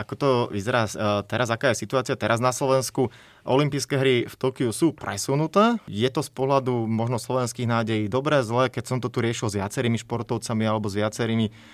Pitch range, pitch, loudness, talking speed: 110-130 Hz, 125 Hz, -24 LUFS, 185 wpm